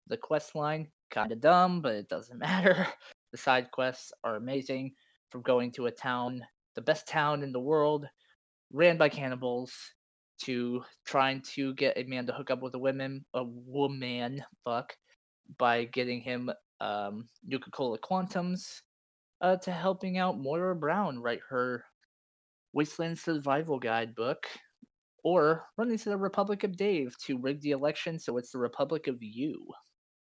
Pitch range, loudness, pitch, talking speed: 125-165 Hz, -32 LUFS, 135 Hz, 160 wpm